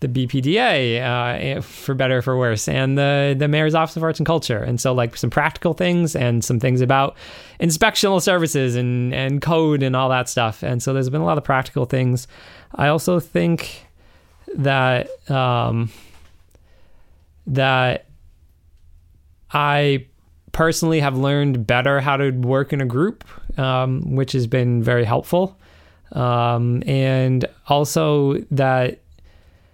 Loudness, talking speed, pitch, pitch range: -19 LUFS, 145 wpm, 130 Hz, 120-145 Hz